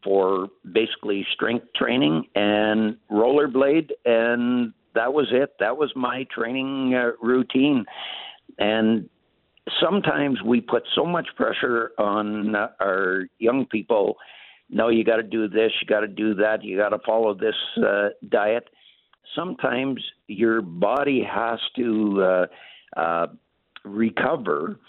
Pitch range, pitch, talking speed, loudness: 105-130 Hz, 115 Hz, 130 wpm, -23 LUFS